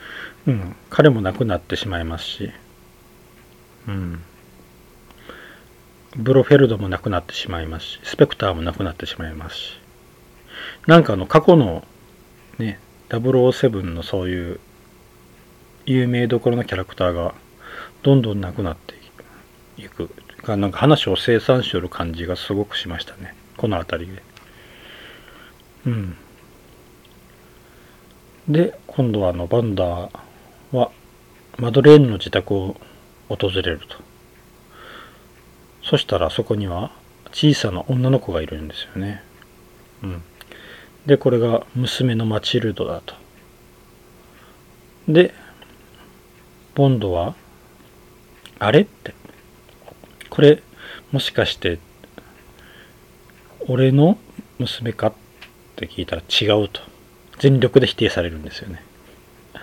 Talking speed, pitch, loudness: 220 characters per minute, 95 Hz, -19 LUFS